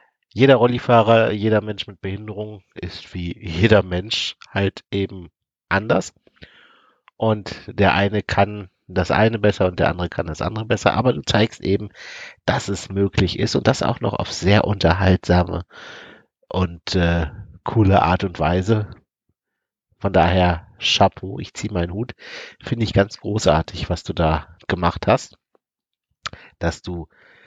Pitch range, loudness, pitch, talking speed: 90-110 Hz, -20 LUFS, 100 Hz, 145 wpm